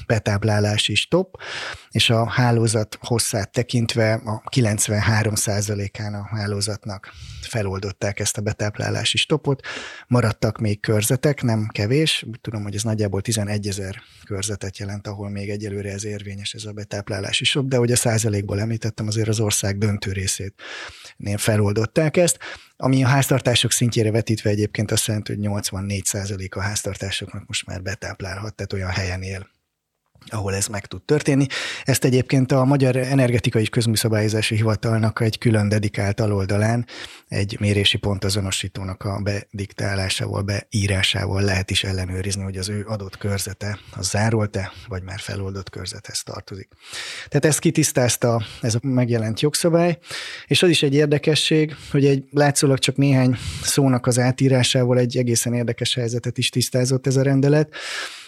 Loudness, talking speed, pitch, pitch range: -21 LUFS, 145 wpm, 110 Hz, 100-125 Hz